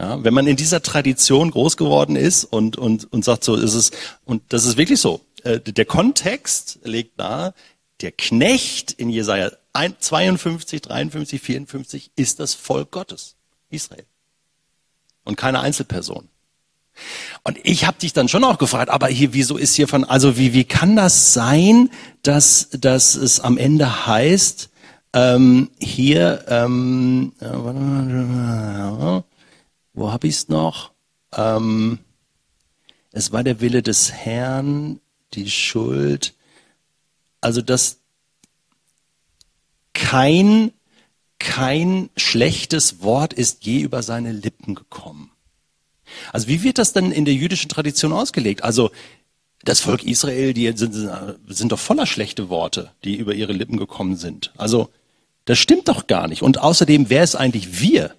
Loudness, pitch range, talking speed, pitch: -17 LUFS, 110-150 Hz, 140 wpm, 130 Hz